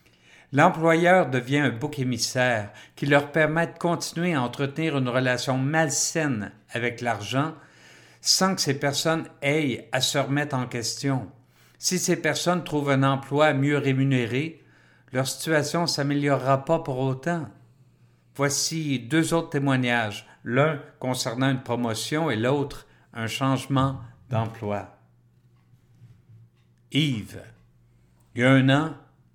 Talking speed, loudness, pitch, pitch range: 125 wpm, -24 LUFS, 135 Hz, 120-150 Hz